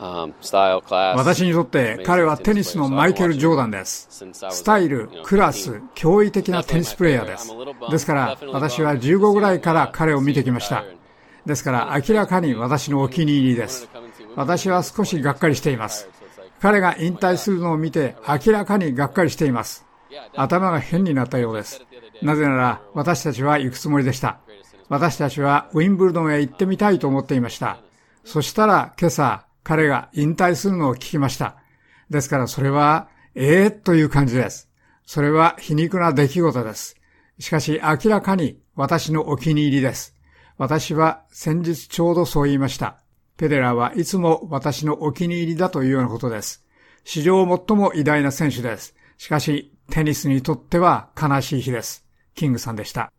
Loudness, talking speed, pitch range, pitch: -20 LUFS, 345 characters per minute, 135-170 Hz, 150 Hz